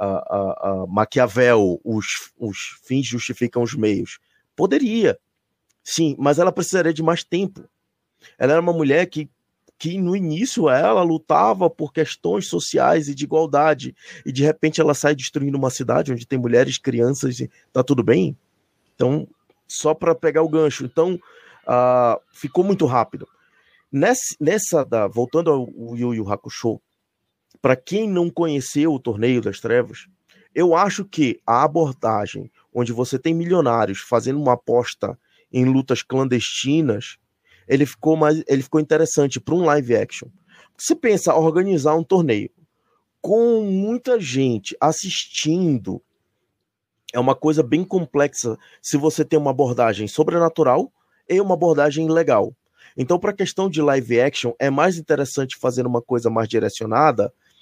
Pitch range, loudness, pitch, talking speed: 125-165 Hz, -20 LUFS, 150 Hz, 150 wpm